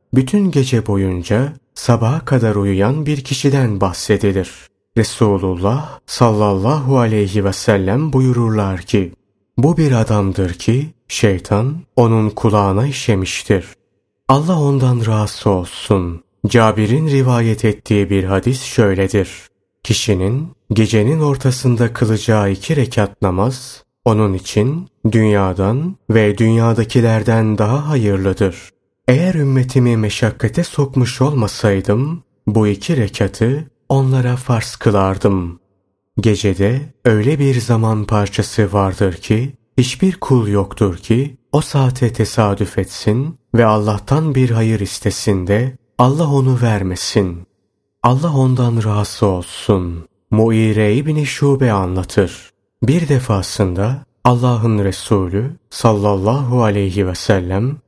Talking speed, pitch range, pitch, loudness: 105 wpm, 100-130 Hz, 110 Hz, -15 LUFS